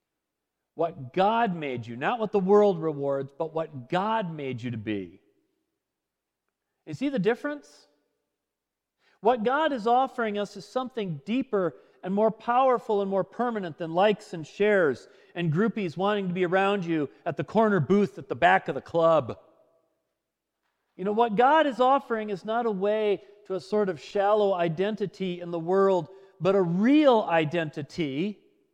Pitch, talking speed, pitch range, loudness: 200 Hz, 165 wpm, 170-225 Hz, -26 LUFS